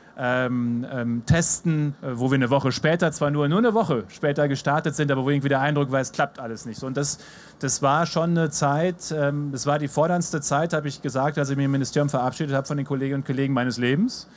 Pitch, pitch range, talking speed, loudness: 145 Hz, 135-155 Hz, 240 wpm, -23 LUFS